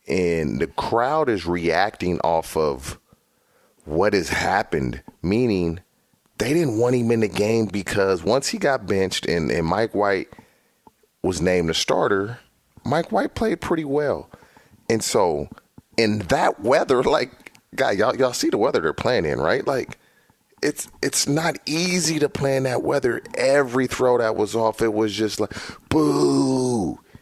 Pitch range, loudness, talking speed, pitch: 95-130 Hz, -22 LUFS, 155 wpm, 110 Hz